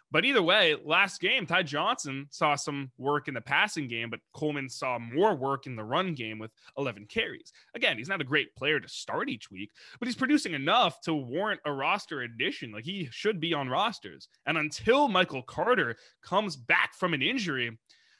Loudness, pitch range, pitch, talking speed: -29 LUFS, 130-180 Hz, 145 Hz, 200 wpm